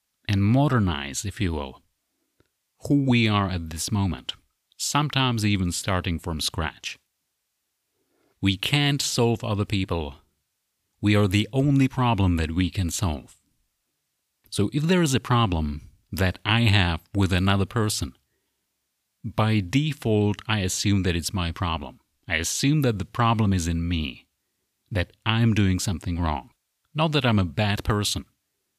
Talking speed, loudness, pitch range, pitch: 145 wpm, -24 LUFS, 90-115 Hz, 100 Hz